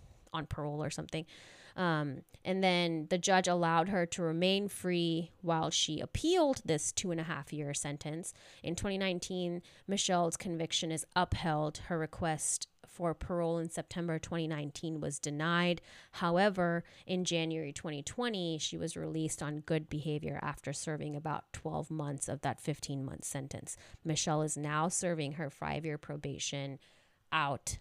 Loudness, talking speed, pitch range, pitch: -35 LUFS, 145 wpm, 150-175 Hz, 160 Hz